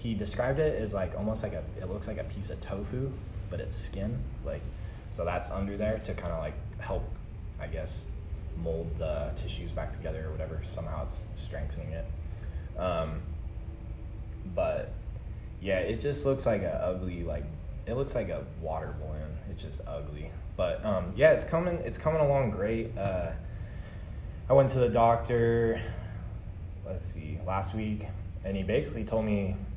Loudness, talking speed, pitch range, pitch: -32 LUFS, 170 wpm, 80-110 Hz, 95 Hz